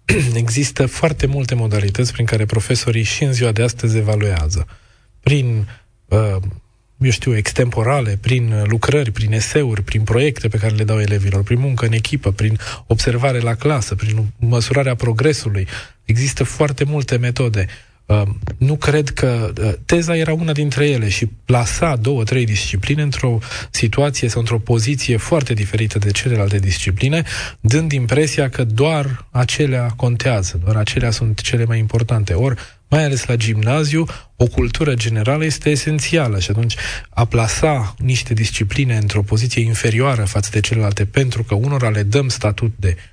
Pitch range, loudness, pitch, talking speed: 110-135 Hz, -17 LUFS, 115 Hz, 150 wpm